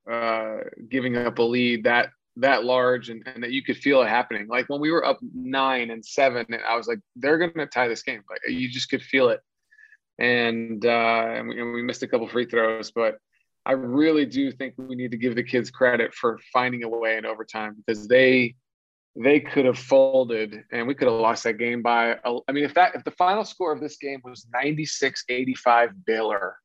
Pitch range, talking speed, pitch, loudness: 115-140 Hz, 215 wpm, 125 Hz, -23 LUFS